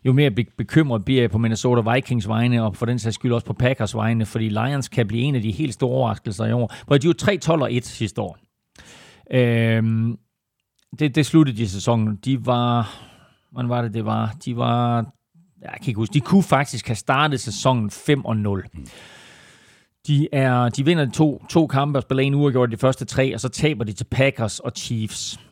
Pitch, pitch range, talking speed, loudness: 120 Hz, 115-135 Hz, 205 wpm, -21 LUFS